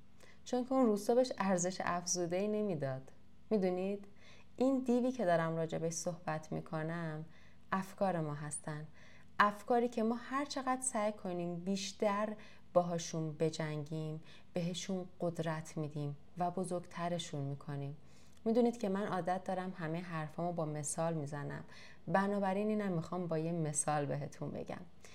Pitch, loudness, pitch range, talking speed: 180 Hz, -37 LUFS, 160-205 Hz, 130 wpm